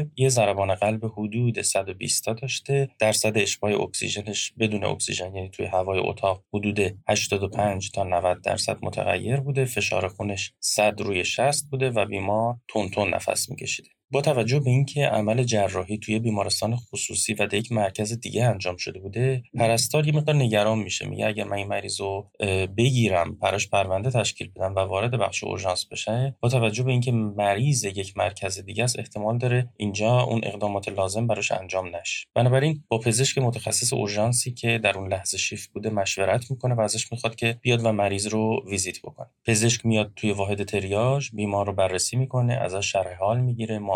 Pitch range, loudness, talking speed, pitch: 100-120 Hz, -24 LUFS, 175 wpm, 110 Hz